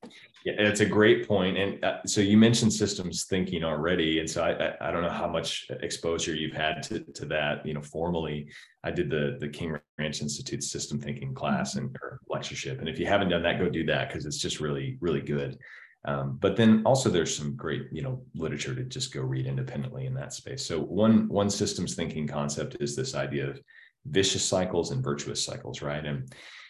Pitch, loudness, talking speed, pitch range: 80 Hz, -28 LUFS, 210 wpm, 70-100 Hz